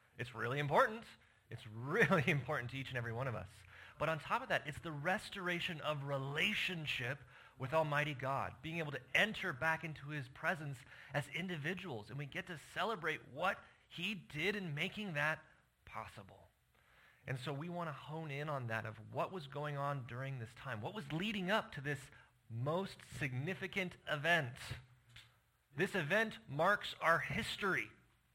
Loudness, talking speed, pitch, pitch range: -39 LUFS, 165 wpm, 145 Hz, 125-175 Hz